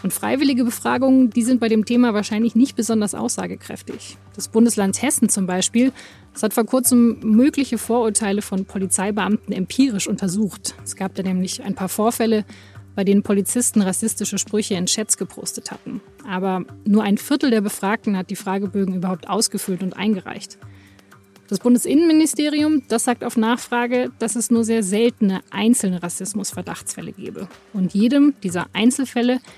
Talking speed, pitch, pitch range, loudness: 150 wpm, 215 Hz, 195-240 Hz, -19 LUFS